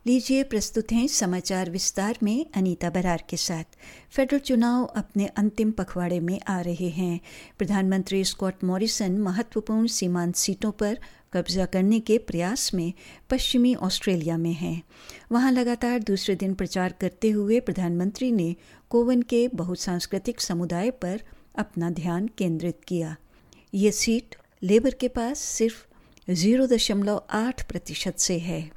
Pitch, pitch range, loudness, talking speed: 195 Hz, 180-230 Hz, -25 LUFS, 135 wpm